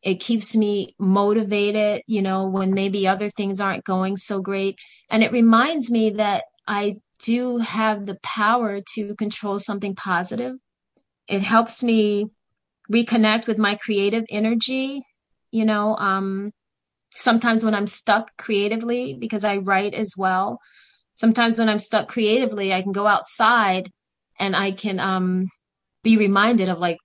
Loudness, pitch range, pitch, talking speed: -21 LUFS, 195-225 Hz, 210 Hz, 145 wpm